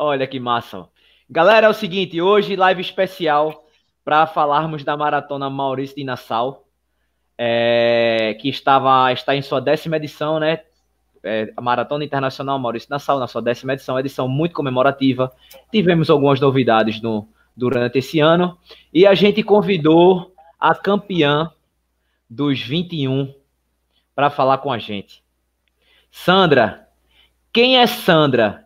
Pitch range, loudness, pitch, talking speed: 120-160 Hz, -17 LUFS, 140 Hz, 135 wpm